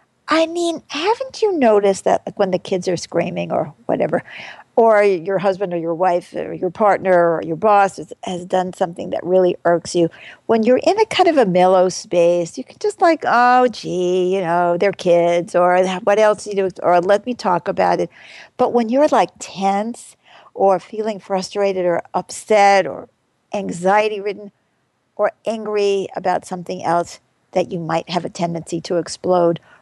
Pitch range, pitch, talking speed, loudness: 175-215 Hz, 190 Hz, 185 wpm, -18 LUFS